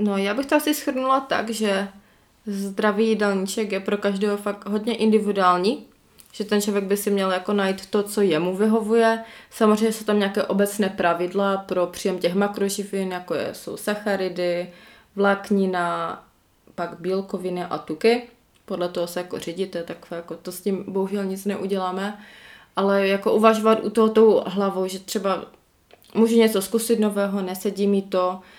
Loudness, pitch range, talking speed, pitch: -22 LUFS, 185-215 Hz, 160 wpm, 200 Hz